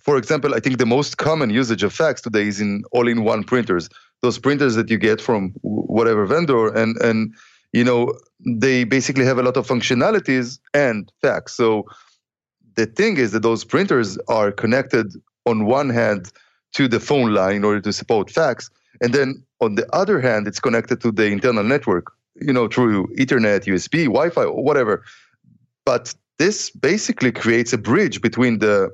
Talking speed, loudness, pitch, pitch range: 175 wpm, -19 LUFS, 115 Hz, 110-125 Hz